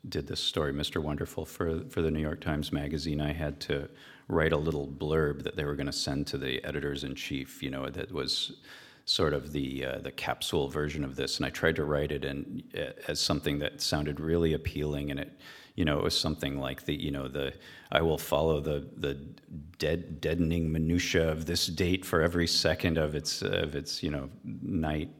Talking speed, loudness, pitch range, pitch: 210 wpm, -31 LUFS, 70-80 Hz, 75 Hz